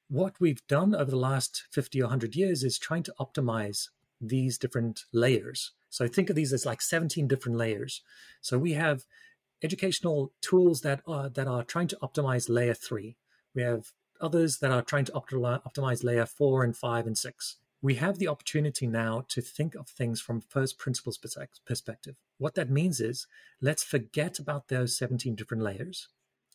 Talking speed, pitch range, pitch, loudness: 175 wpm, 120-150 Hz, 135 Hz, -30 LUFS